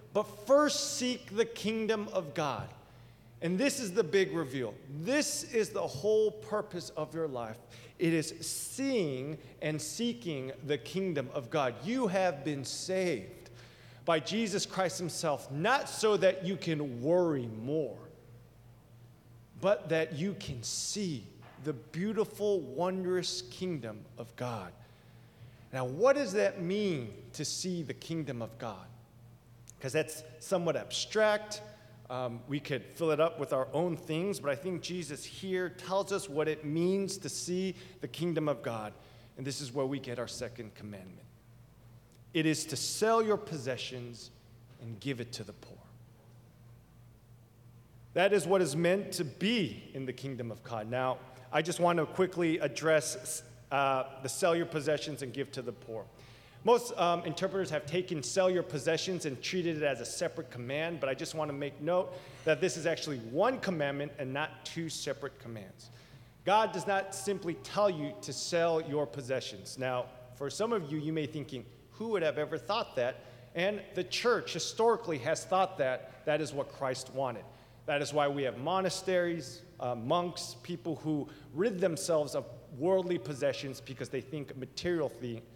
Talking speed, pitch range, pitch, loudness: 165 wpm, 125-180 Hz, 150 Hz, -33 LUFS